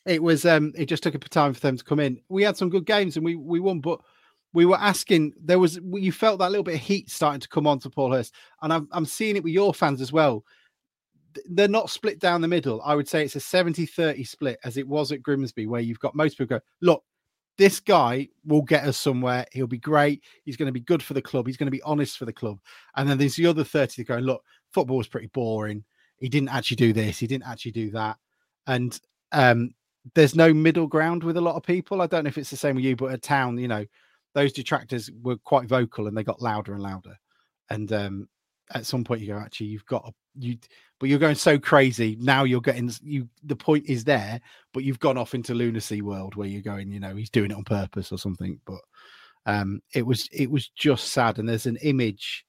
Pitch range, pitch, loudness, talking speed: 120-155 Hz, 135 Hz, -24 LUFS, 250 wpm